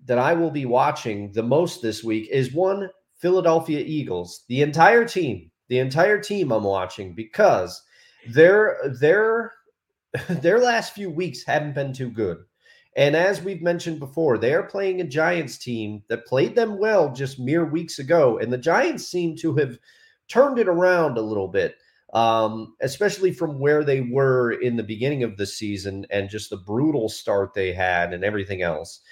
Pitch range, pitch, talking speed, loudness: 110-180 Hz, 150 Hz, 175 wpm, -22 LUFS